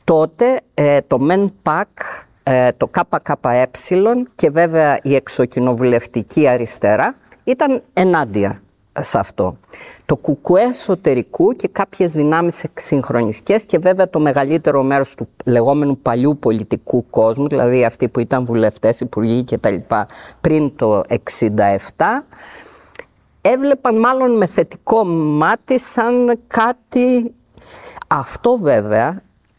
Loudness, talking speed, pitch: -16 LUFS, 105 wpm, 150 Hz